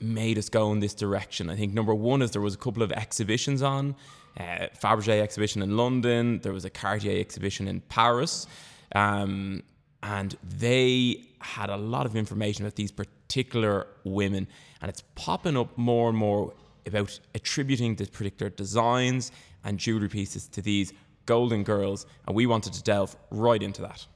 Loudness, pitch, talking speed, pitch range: -28 LUFS, 105 Hz, 170 wpm, 100-120 Hz